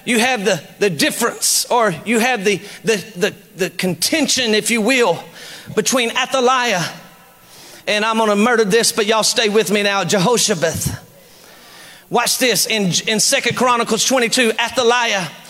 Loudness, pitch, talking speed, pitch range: -16 LUFS, 225 Hz, 150 wpm, 205-240 Hz